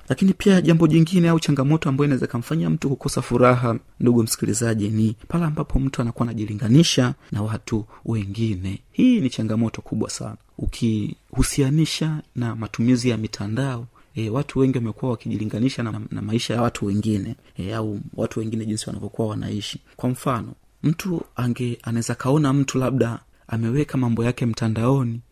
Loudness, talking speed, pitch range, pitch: -22 LUFS, 150 wpm, 110-135 Hz, 120 Hz